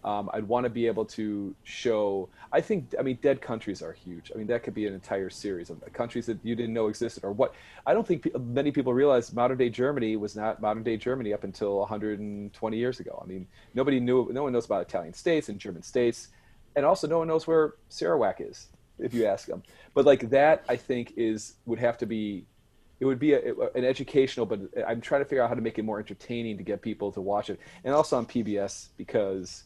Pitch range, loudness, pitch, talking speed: 105-130 Hz, -28 LUFS, 115 Hz, 235 wpm